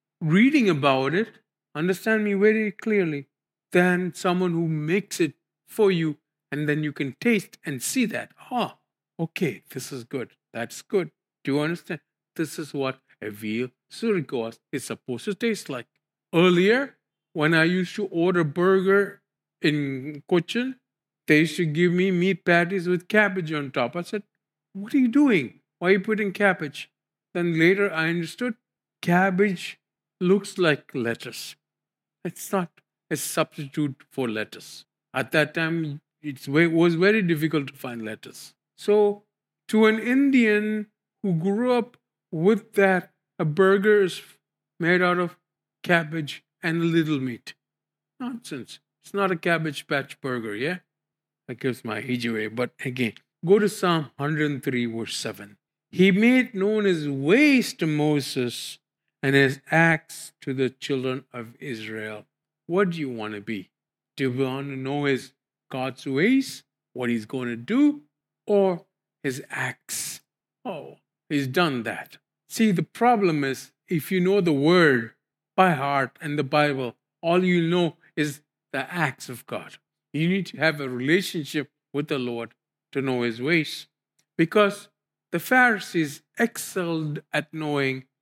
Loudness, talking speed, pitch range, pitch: -24 LUFS, 150 wpm, 140-190 Hz, 160 Hz